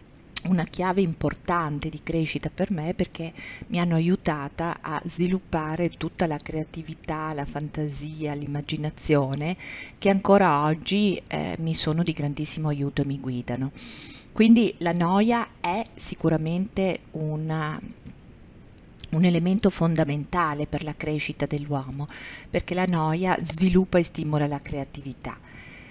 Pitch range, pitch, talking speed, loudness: 150-180 Hz, 160 Hz, 120 wpm, -26 LUFS